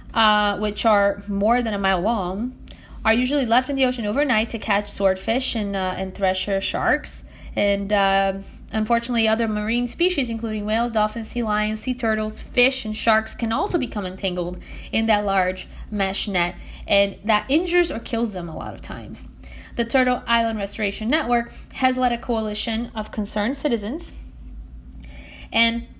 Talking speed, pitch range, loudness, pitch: 165 wpm, 195-235 Hz, -22 LUFS, 215 Hz